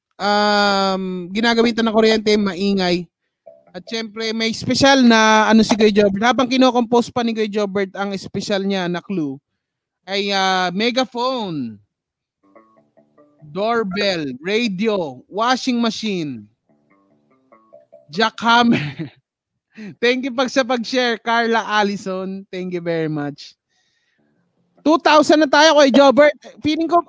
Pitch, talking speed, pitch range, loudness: 210 Hz, 115 wpm, 175-235 Hz, -17 LUFS